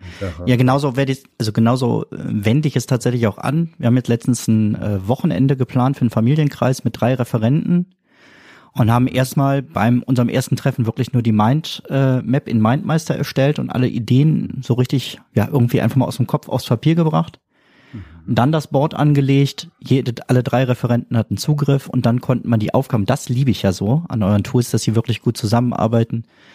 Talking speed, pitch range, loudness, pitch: 195 wpm, 115-140 Hz, -18 LUFS, 125 Hz